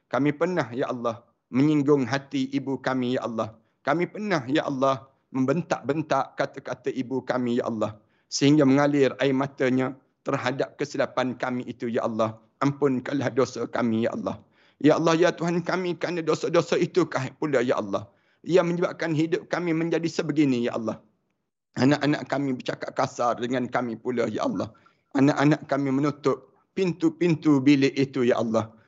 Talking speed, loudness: 150 wpm, -25 LUFS